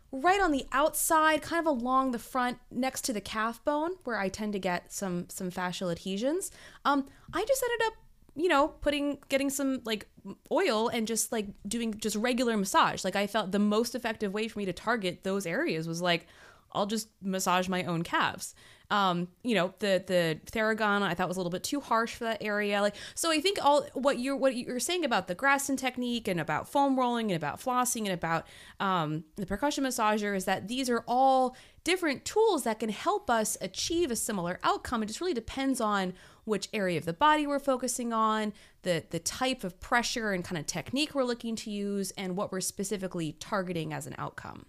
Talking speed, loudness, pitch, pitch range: 210 wpm, -30 LUFS, 220 Hz, 190-265 Hz